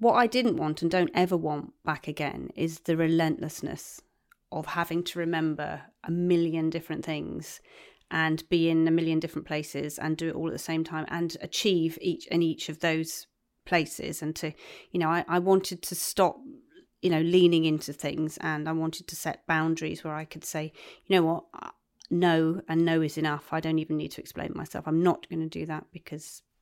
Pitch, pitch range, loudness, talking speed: 165 Hz, 155-175 Hz, -28 LUFS, 205 wpm